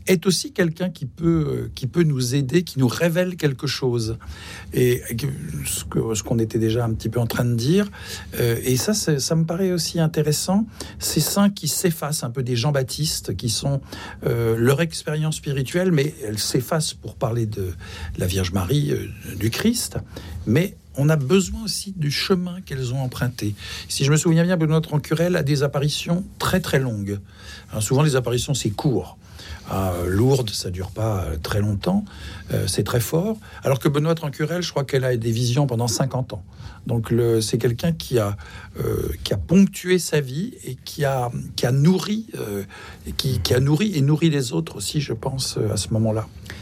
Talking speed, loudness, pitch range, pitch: 195 wpm, -22 LUFS, 110-160 Hz, 135 Hz